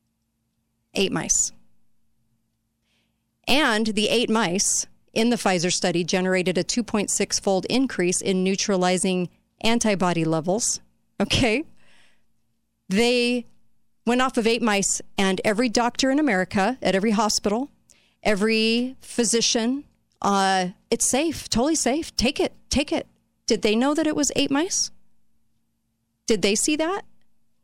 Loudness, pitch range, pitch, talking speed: -22 LUFS, 180-240 Hz, 215 Hz, 125 wpm